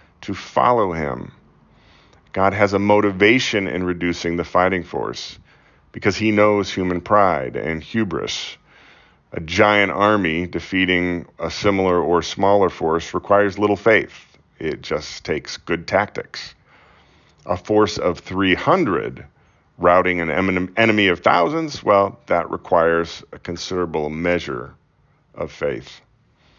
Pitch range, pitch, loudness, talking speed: 90-105 Hz, 95 Hz, -19 LUFS, 120 wpm